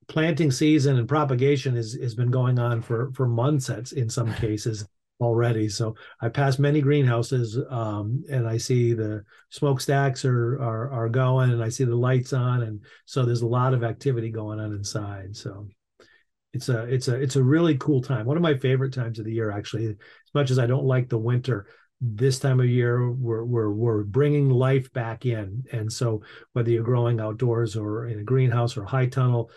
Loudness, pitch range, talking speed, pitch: -24 LUFS, 115-130 Hz, 205 wpm, 125 Hz